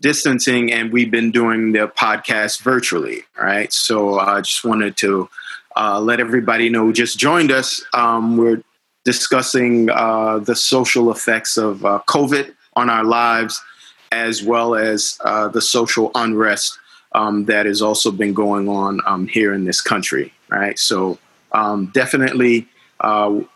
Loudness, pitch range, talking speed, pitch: -16 LUFS, 105-120 Hz, 150 wpm, 115 Hz